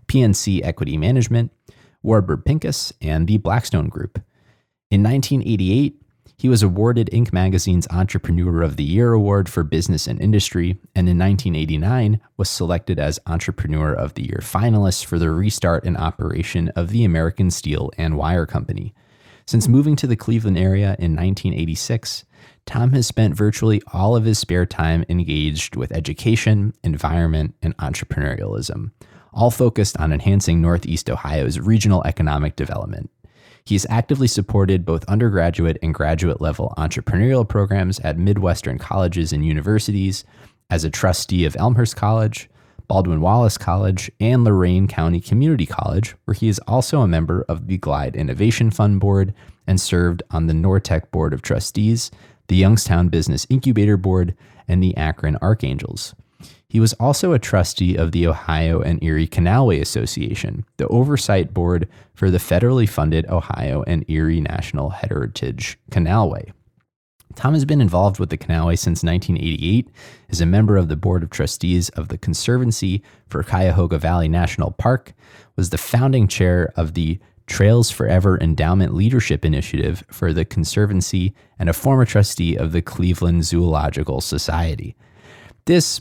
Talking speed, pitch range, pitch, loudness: 150 wpm, 85-110 Hz, 95 Hz, -19 LUFS